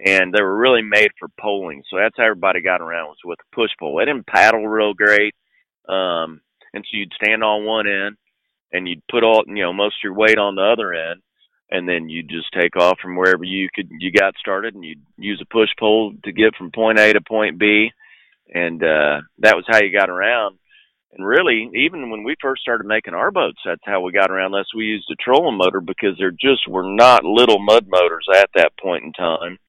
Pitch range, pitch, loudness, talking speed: 90-110 Hz, 100 Hz, -17 LUFS, 230 wpm